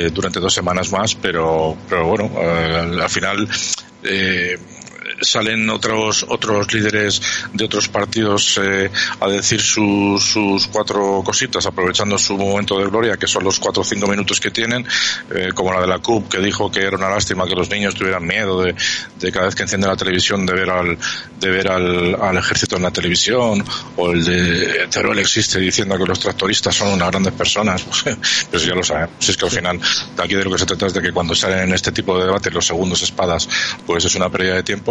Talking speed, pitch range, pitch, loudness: 215 wpm, 90-100 Hz, 95 Hz, -16 LUFS